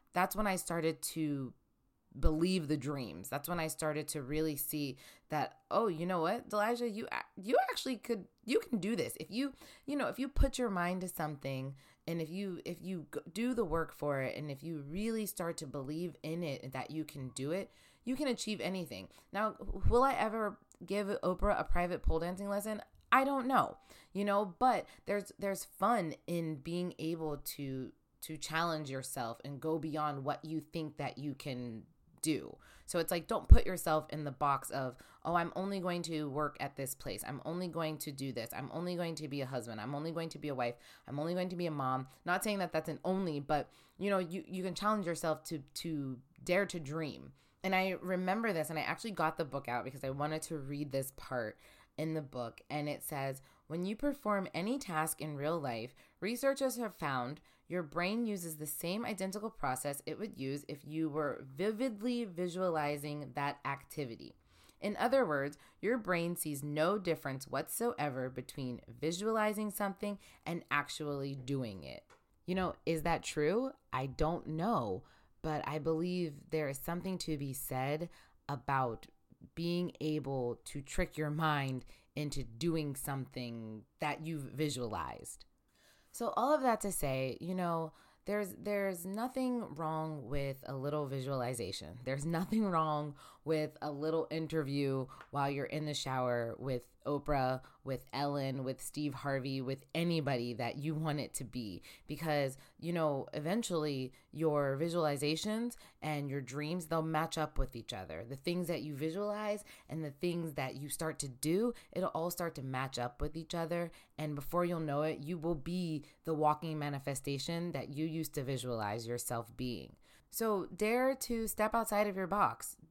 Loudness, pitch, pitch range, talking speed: -37 LUFS, 155 Hz, 140-180 Hz, 185 wpm